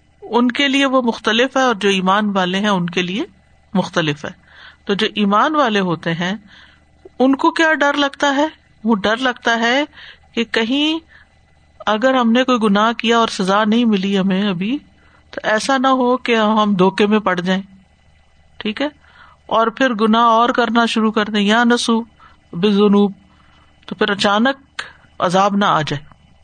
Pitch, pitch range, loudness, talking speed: 220 Hz, 195-250 Hz, -16 LUFS, 175 wpm